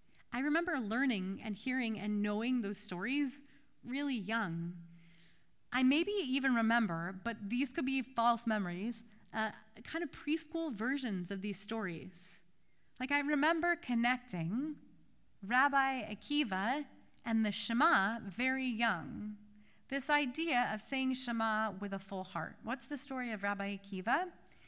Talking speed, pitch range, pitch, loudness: 135 wpm, 205-270 Hz, 235 Hz, -36 LUFS